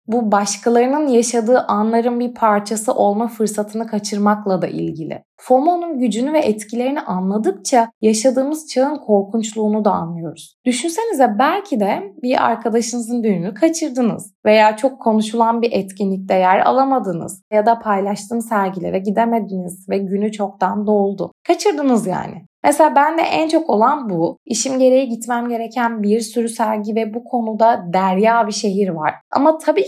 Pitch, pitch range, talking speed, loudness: 230 Hz, 205-255 Hz, 135 wpm, -17 LUFS